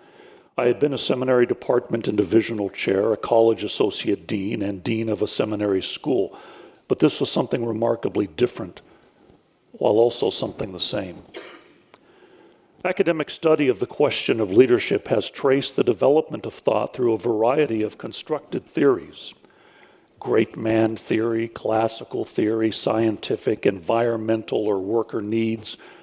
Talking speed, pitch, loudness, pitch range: 135 wpm, 115 Hz, -22 LUFS, 110-140 Hz